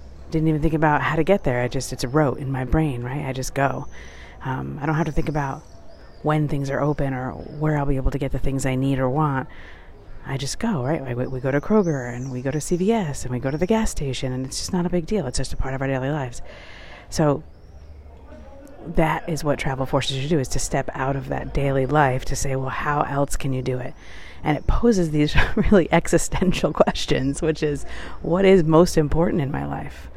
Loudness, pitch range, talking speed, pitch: -23 LUFS, 130-160 Hz, 245 wpm, 140 Hz